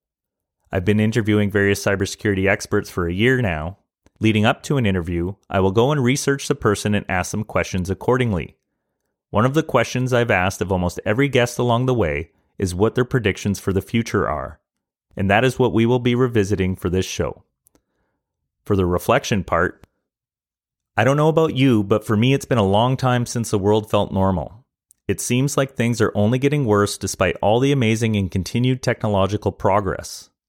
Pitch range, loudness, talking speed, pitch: 95-125 Hz, -20 LUFS, 190 wpm, 105 Hz